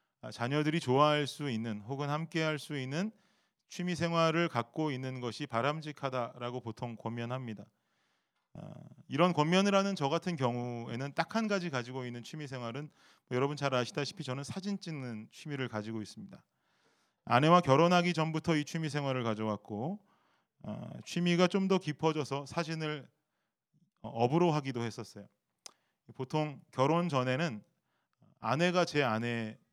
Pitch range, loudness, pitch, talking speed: 120-165 Hz, -33 LUFS, 145 Hz, 305 characters per minute